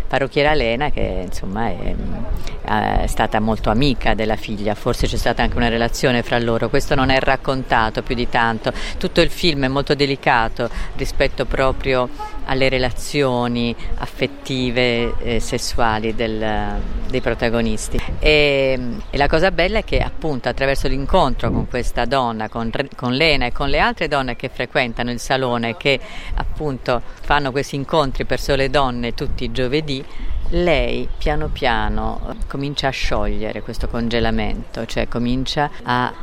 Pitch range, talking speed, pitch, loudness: 115-140 Hz, 145 wpm, 125 Hz, -20 LUFS